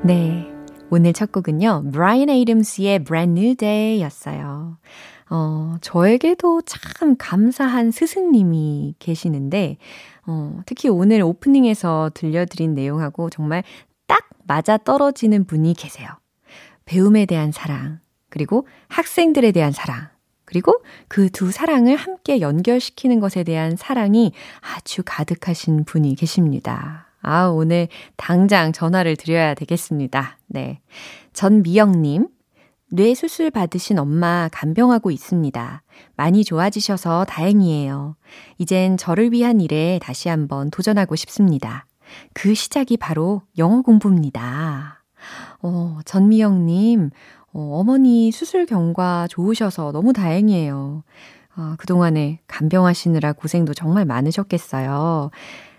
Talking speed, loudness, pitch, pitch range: 275 characters per minute, -18 LUFS, 175 Hz, 155-215 Hz